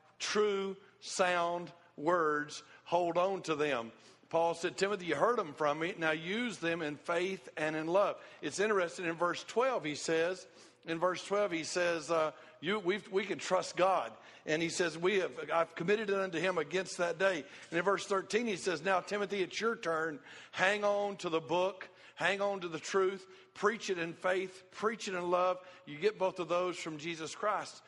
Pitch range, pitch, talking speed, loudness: 165-195 Hz, 180 Hz, 200 wpm, -34 LUFS